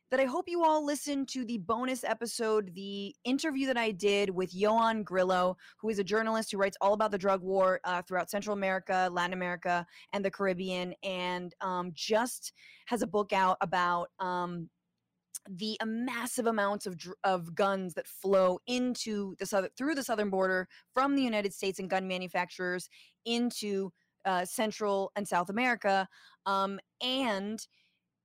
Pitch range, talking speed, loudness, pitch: 185-225 Hz, 165 wpm, -32 LUFS, 200 Hz